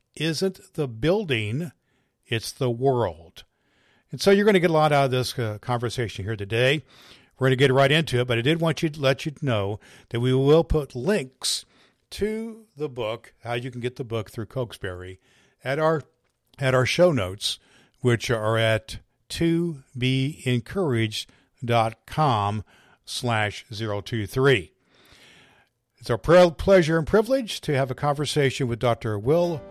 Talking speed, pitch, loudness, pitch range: 160 wpm, 130 Hz, -24 LUFS, 115-155 Hz